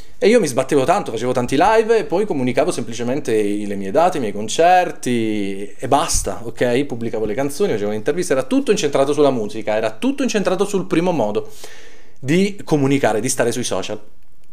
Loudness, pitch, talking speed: -18 LUFS, 135 Hz, 180 wpm